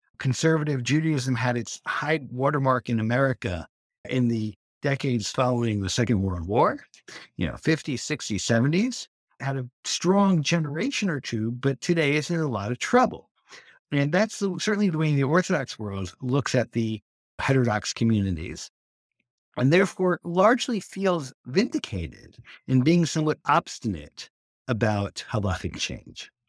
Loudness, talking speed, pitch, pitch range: -25 LUFS, 140 wpm, 135 Hz, 115-170 Hz